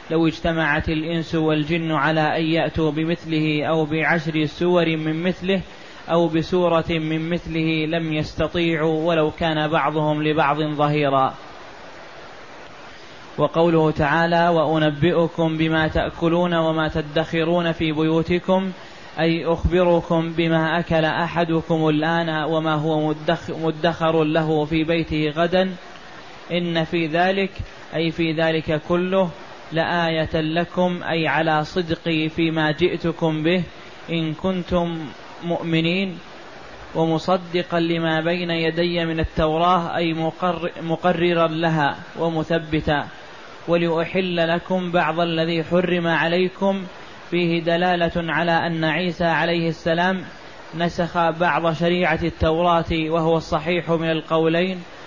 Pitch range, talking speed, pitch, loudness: 160-170 Hz, 105 wpm, 165 Hz, -21 LUFS